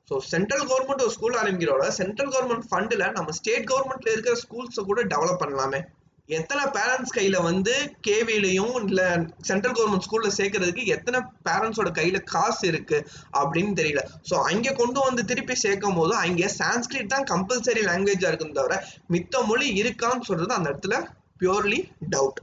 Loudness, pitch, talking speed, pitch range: -24 LUFS, 220 Hz, 150 wpm, 185-250 Hz